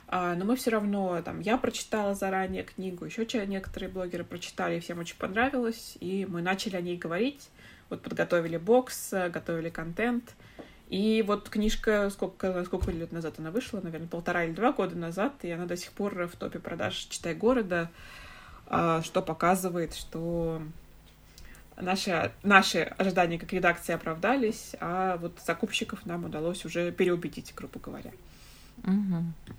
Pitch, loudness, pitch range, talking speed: 185 Hz, -30 LUFS, 170-210 Hz, 140 wpm